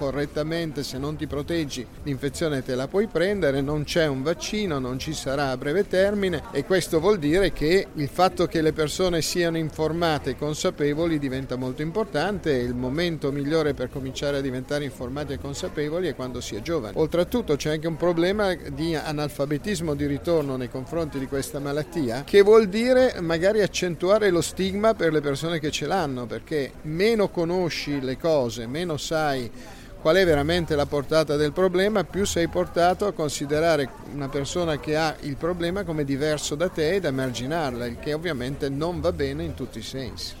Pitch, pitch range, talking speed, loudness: 155 Hz, 140-175 Hz, 180 wpm, -25 LUFS